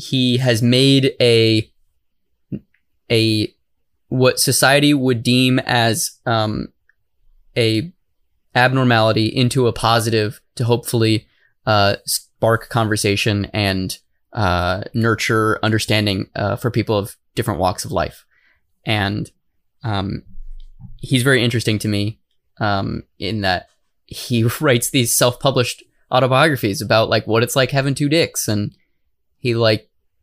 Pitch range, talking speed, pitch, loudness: 110-130 Hz, 115 wpm, 115 Hz, -17 LUFS